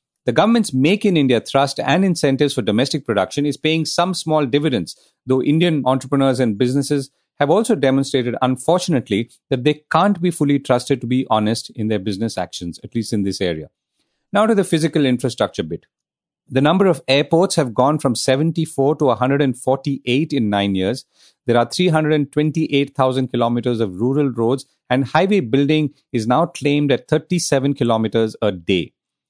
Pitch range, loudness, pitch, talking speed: 125-155 Hz, -18 LUFS, 135 Hz, 165 wpm